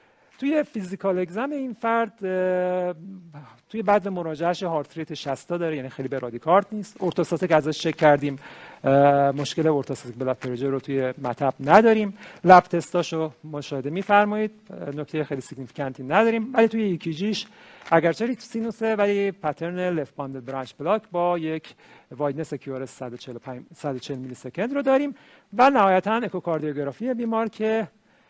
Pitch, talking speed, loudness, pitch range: 170 Hz, 130 wpm, -24 LUFS, 140-210 Hz